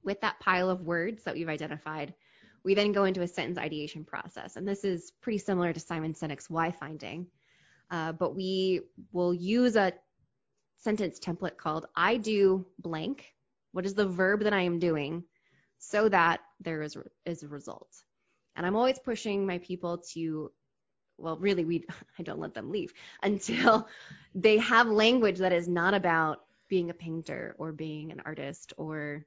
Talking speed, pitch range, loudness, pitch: 170 wpm, 160-200 Hz, -30 LUFS, 180 Hz